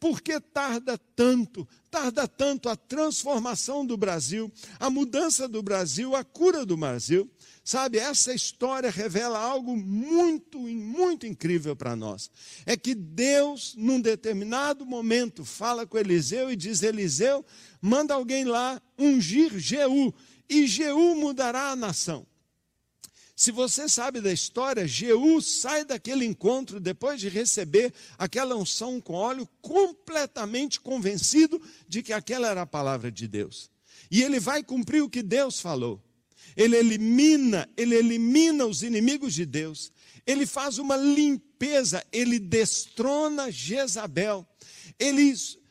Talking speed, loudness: 130 wpm, -26 LUFS